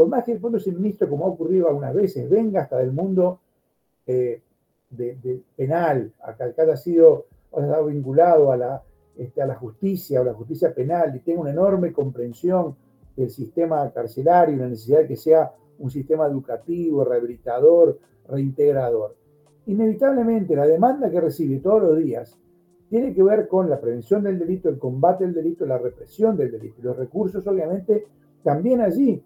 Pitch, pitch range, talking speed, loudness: 165 Hz, 135-195 Hz, 175 wpm, -21 LUFS